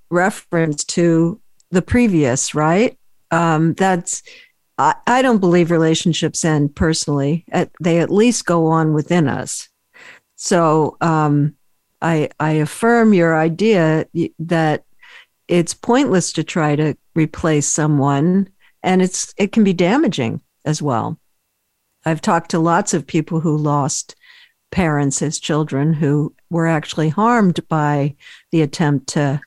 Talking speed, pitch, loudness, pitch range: 130 wpm, 165 Hz, -17 LUFS, 150-185 Hz